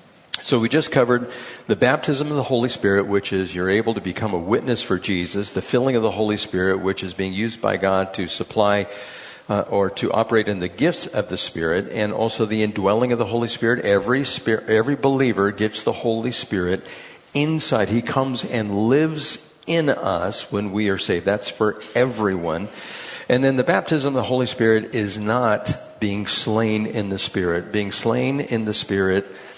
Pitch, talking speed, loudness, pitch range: 110 Hz, 190 wpm, -21 LUFS, 100-125 Hz